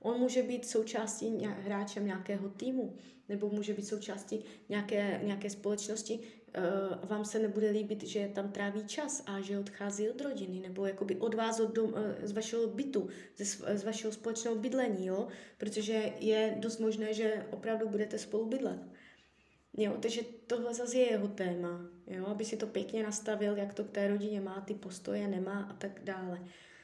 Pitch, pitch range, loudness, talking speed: 210 Hz, 200-225 Hz, -36 LUFS, 170 wpm